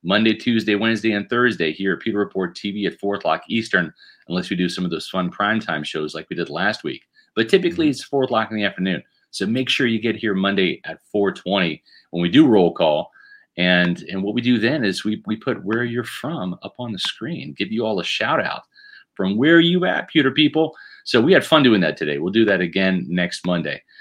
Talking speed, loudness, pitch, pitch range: 230 wpm, -20 LUFS, 105 Hz, 90-115 Hz